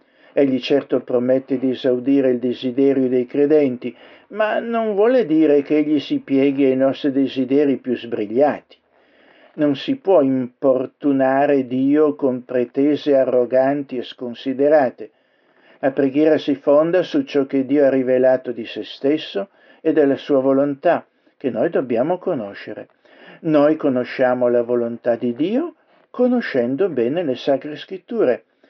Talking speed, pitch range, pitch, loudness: 135 wpm, 130-150 Hz, 140 Hz, -18 LUFS